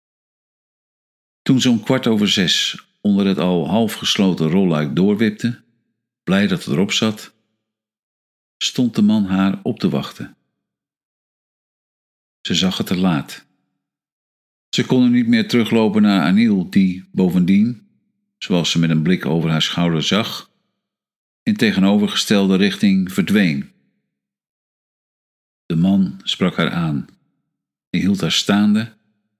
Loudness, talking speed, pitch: -17 LUFS, 125 wpm, 110 Hz